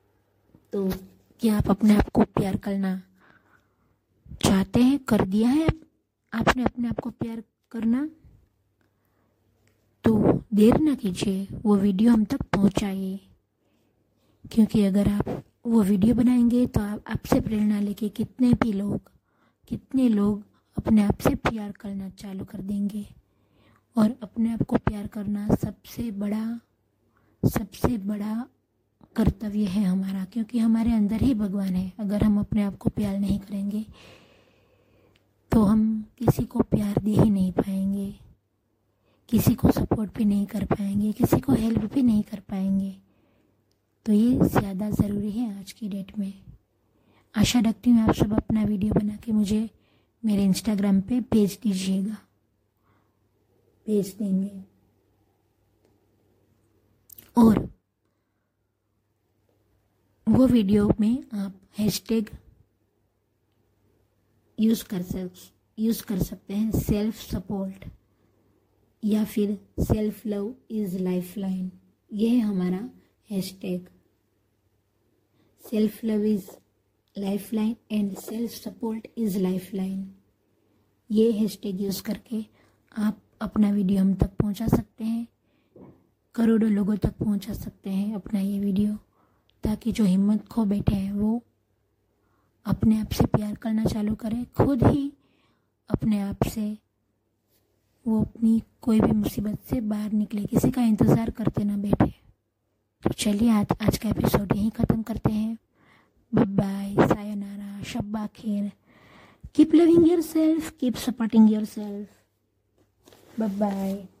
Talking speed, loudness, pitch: 125 wpm, -25 LUFS, 205 Hz